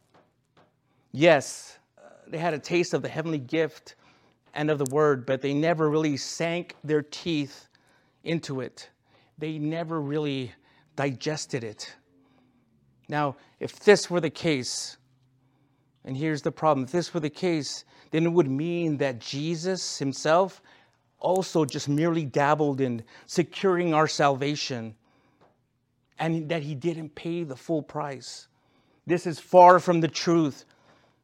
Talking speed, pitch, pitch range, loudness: 135 wpm, 150 Hz, 135-165 Hz, -26 LUFS